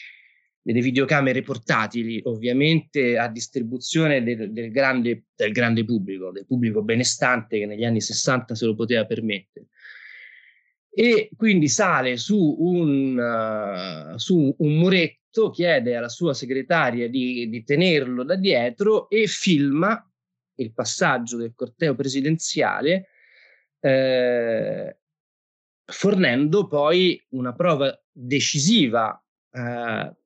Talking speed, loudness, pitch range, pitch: 110 wpm, -22 LUFS, 120-160 Hz, 130 Hz